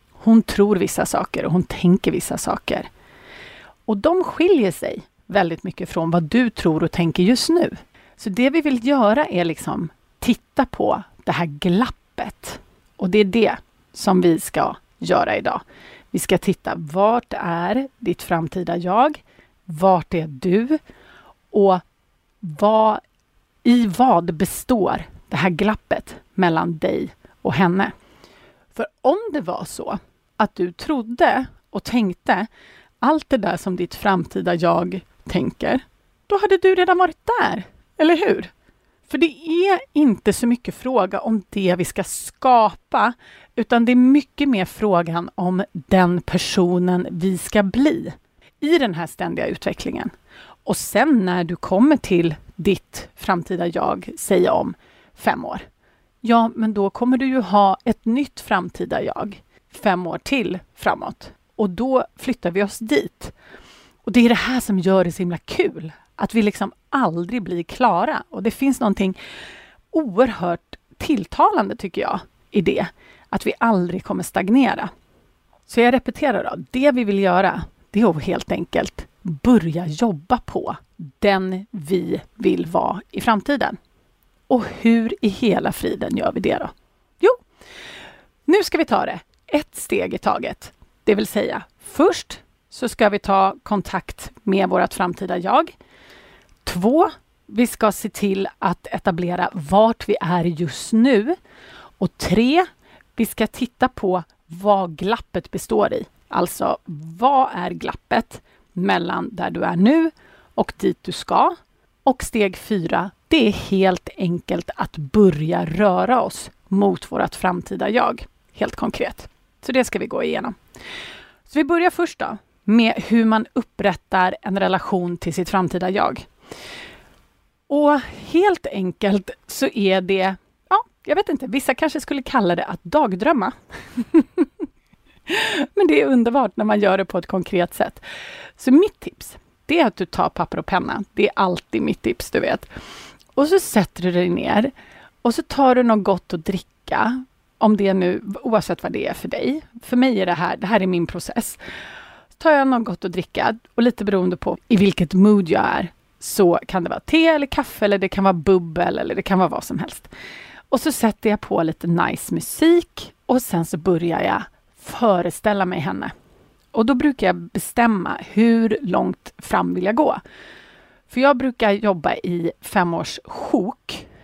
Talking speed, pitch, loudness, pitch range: 160 wpm, 205 Hz, -20 LUFS, 180-255 Hz